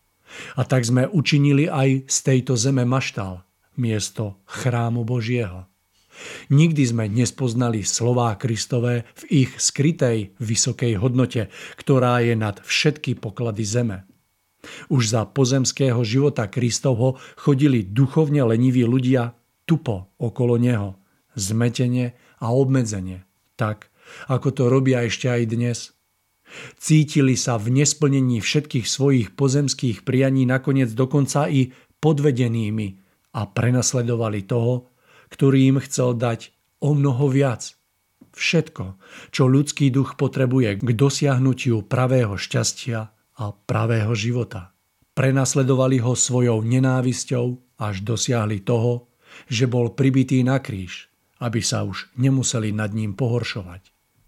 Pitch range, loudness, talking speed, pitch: 115-135 Hz, -21 LUFS, 115 wpm, 125 Hz